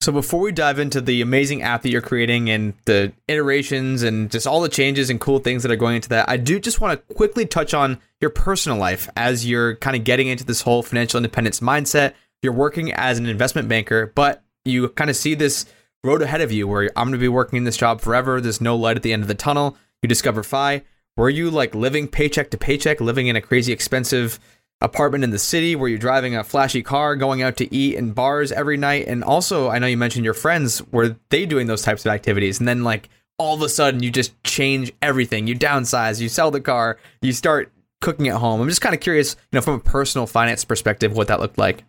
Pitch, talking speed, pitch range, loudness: 125 Hz, 245 wpm, 115-145 Hz, -19 LUFS